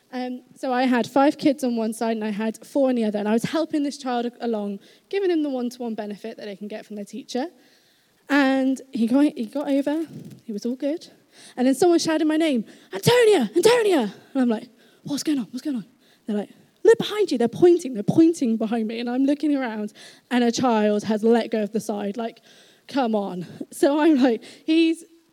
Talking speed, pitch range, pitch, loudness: 225 wpm, 225-295 Hz, 250 Hz, -22 LUFS